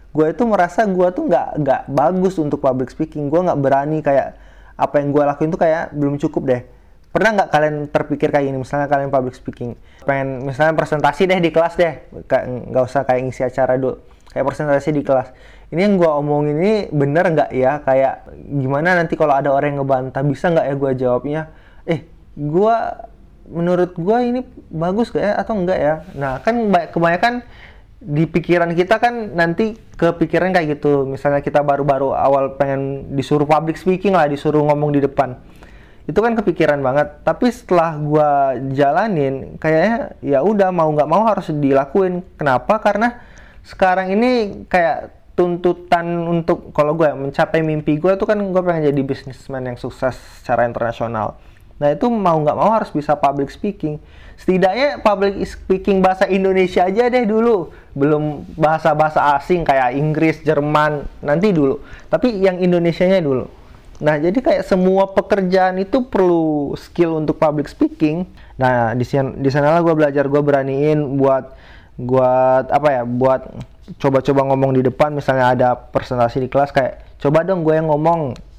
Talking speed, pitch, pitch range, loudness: 165 wpm, 150 Hz, 135-180 Hz, -17 LUFS